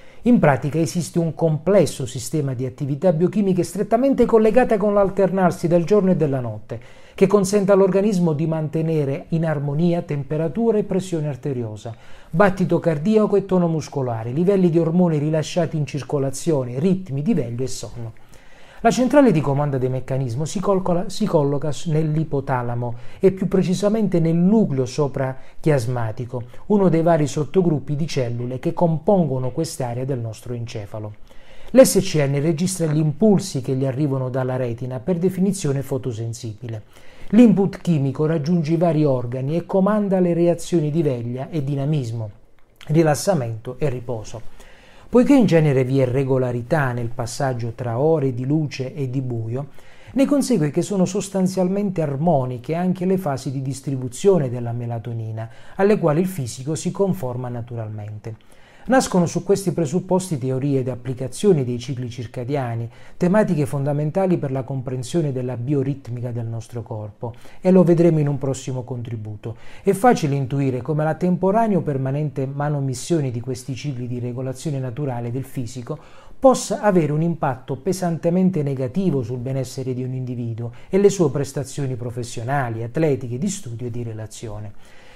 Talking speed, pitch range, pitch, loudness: 145 wpm, 130-175 Hz, 145 Hz, -21 LUFS